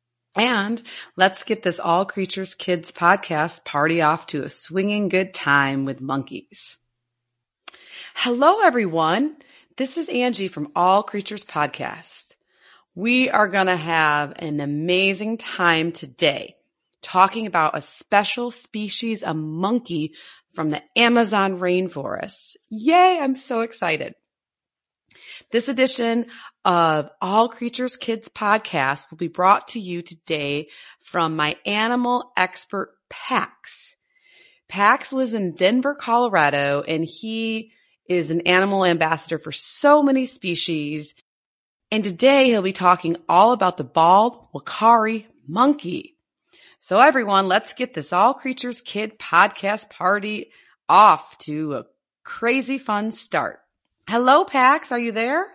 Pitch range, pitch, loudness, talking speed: 165-240 Hz, 200 Hz, -20 LUFS, 125 wpm